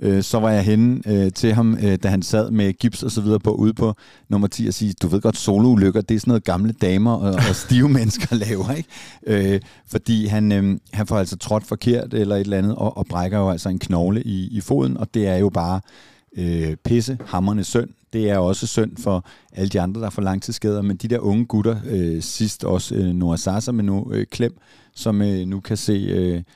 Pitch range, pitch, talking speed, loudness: 95-115 Hz, 105 Hz, 235 wpm, -20 LUFS